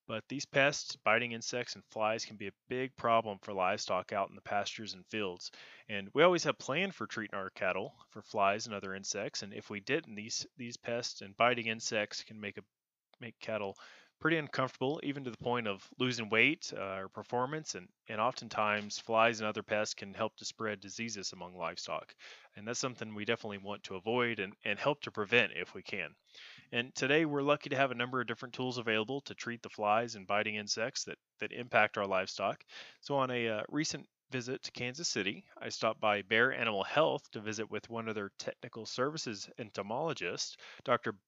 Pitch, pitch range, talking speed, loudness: 115 Hz, 105-125 Hz, 205 wpm, -35 LUFS